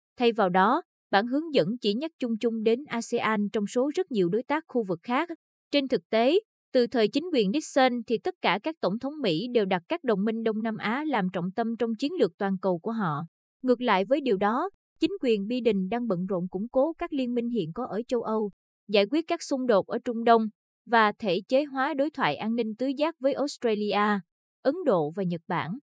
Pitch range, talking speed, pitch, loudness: 205-265 Hz, 230 wpm, 230 Hz, -27 LUFS